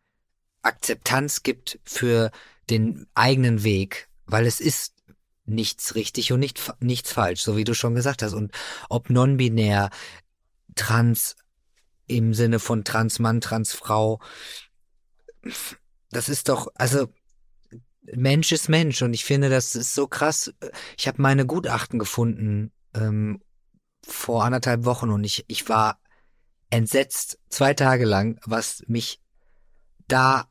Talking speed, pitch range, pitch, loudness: 130 wpm, 110-130 Hz, 115 Hz, -23 LUFS